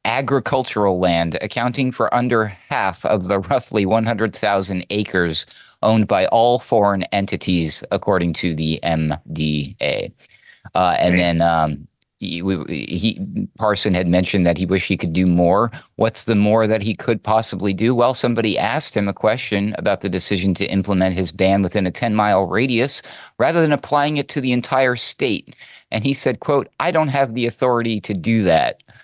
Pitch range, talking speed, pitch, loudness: 90-120 Hz, 175 wpm, 105 Hz, -18 LUFS